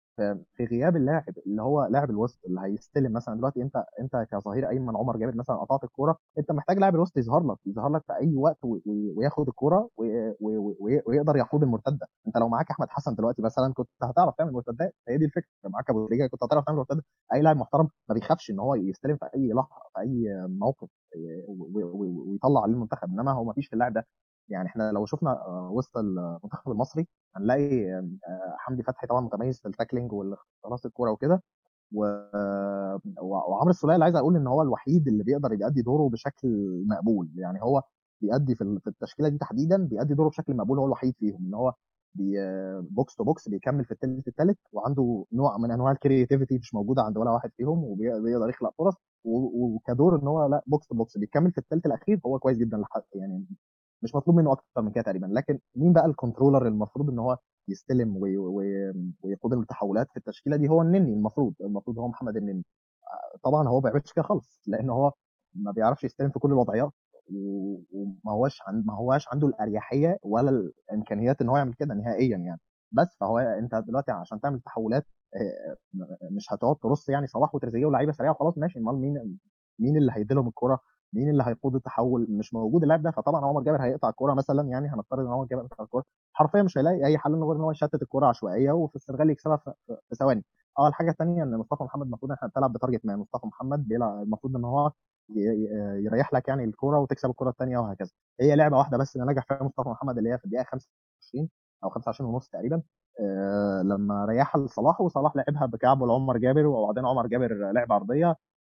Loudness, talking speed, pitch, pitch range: -27 LUFS, 190 wpm, 130 Hz, 110-145 Hz